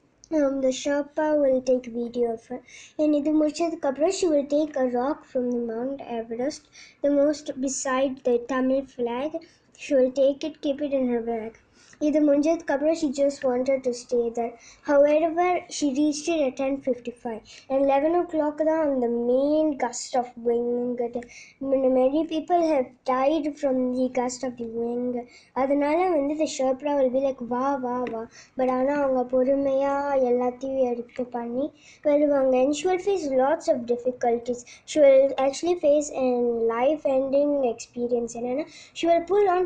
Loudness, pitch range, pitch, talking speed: -24 LUFS, 245-295 Hz, 270 Hz, 150 wpm